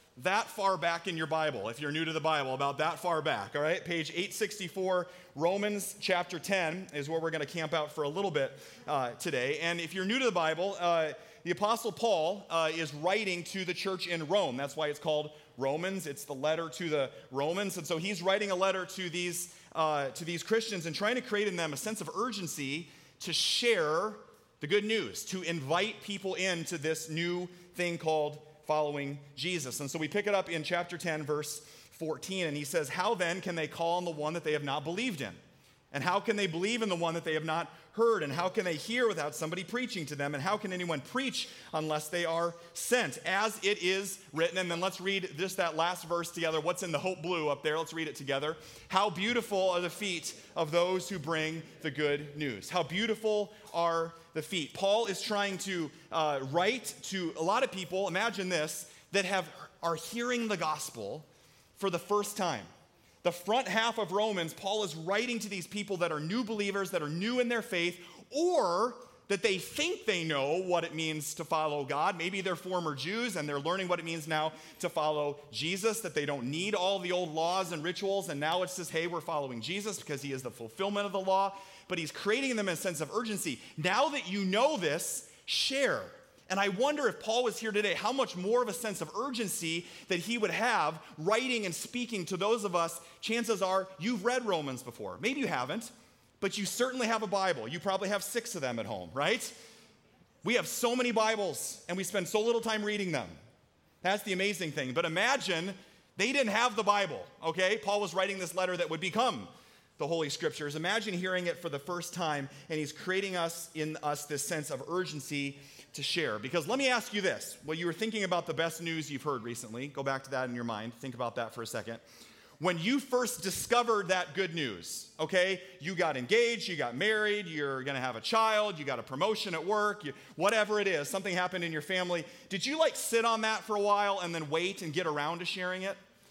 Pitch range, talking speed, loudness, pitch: 155-205 Hz, 220 wpm, -33 LUFS, 180 Hz